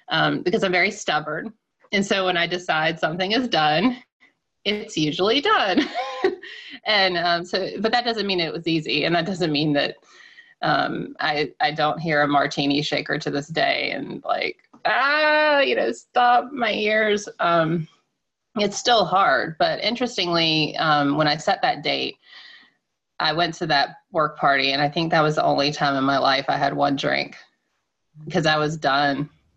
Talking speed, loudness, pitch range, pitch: 175 wpm, -21 LUFS, 150-225 Hz, 170 Hz